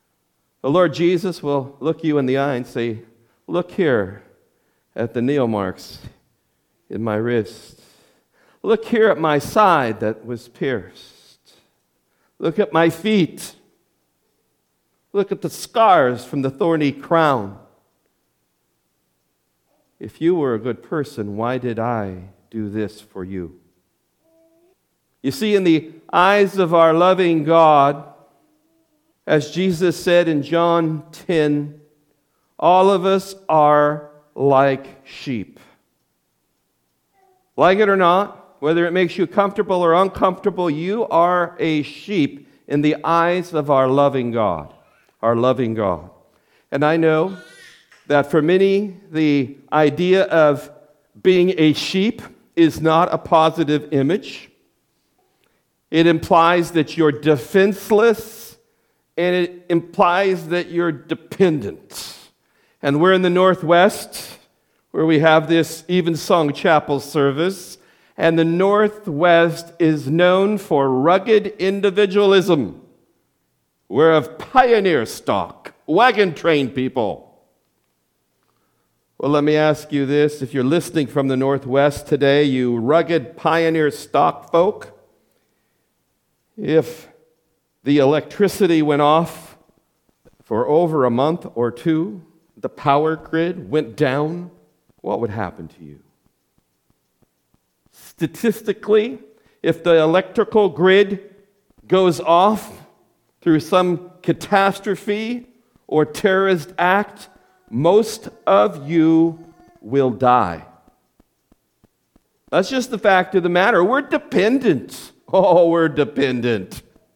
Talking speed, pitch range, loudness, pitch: 115 wpm, 140-185 Hz, -18 LUFS, 160 Hz